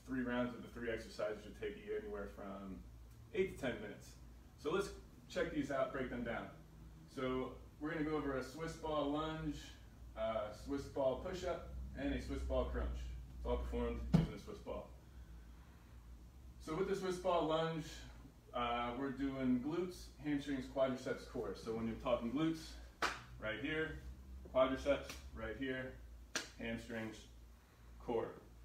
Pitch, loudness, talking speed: 115 Hz, -42 LUFS, 155 wpm